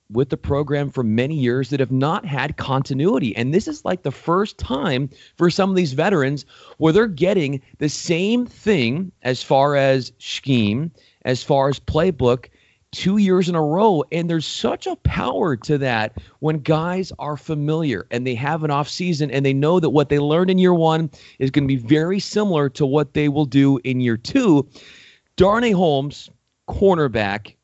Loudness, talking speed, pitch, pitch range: -19 LUFS, 185 wpm, 150 Hz, 135-175 Hz